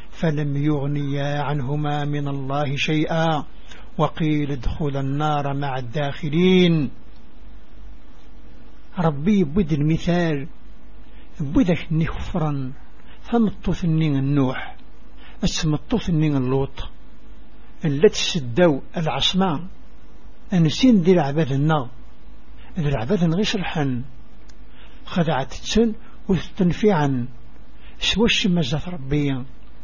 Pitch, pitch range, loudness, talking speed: 155 Hz, 140-180 Hz, -21 LUFS, 75 wpm